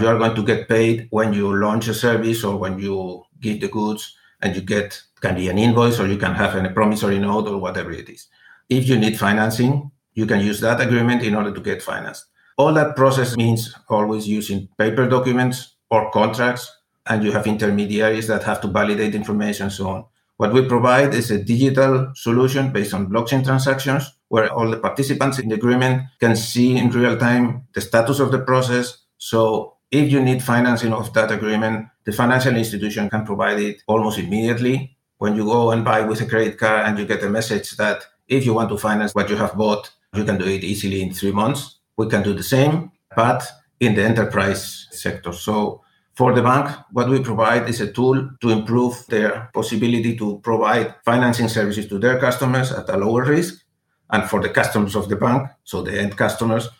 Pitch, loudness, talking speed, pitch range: 115 Hz, -19 LUFS, 205 wpm, 105-125 Hz